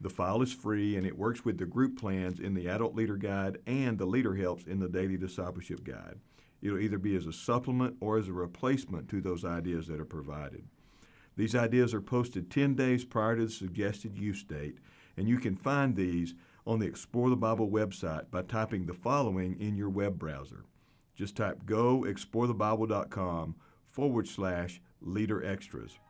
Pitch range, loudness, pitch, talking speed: 90-115 Hz, -33 LUFS, 100 Hz, 185 wpm